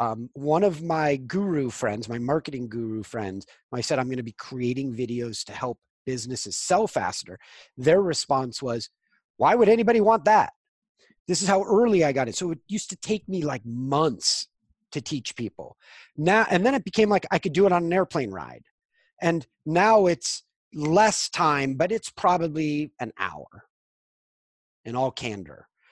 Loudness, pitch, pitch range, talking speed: -24 LUFS, 155 Hz, 125-195 Hz, 180 wpm